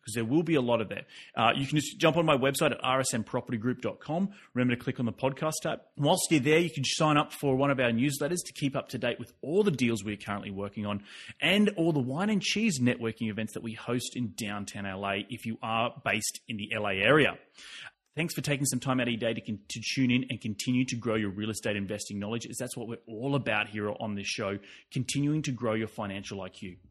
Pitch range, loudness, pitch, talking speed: 110-140 Hz, -30 LUFS, 120 Hz, 250 wpm